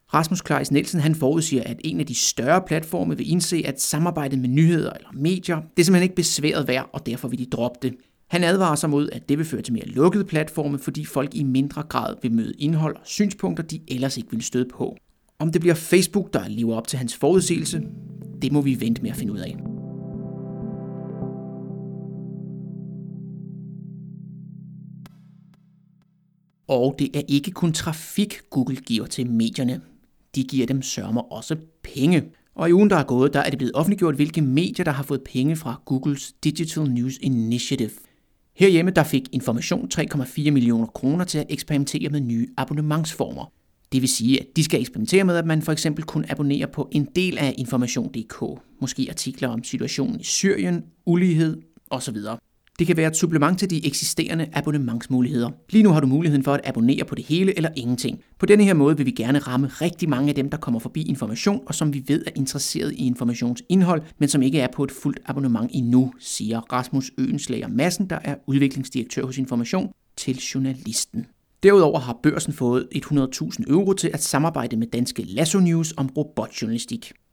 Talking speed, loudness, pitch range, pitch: 185 wpm, -22 LUFS, 130-170 Hz, 145 Hz